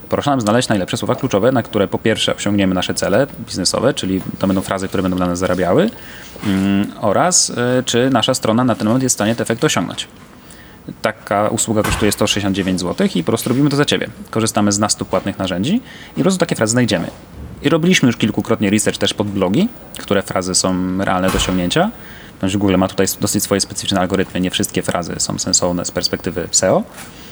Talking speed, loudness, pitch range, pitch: 195 wpm, -16 LUFS, 95-115 Hz, 105 Hz